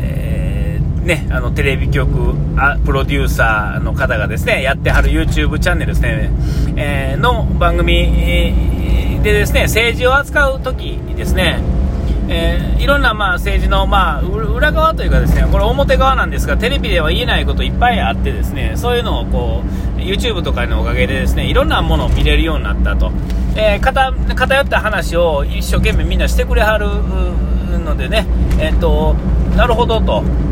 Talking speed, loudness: 370 characters per minute, -15 LUFS